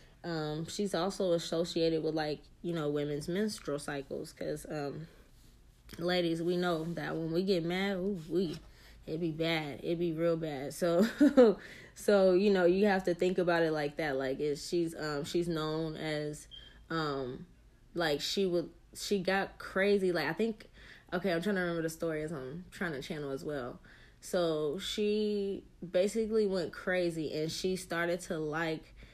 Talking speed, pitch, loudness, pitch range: 170 wpm, 170 Hz, -33 LUFS, 155-185 Hz